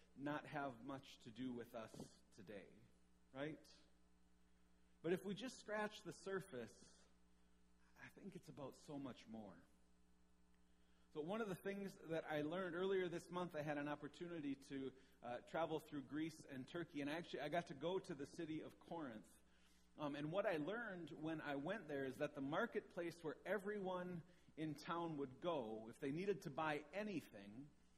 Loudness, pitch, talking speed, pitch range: -49 LUFS, 150 Hz, 175 wpm, 110-175 Hz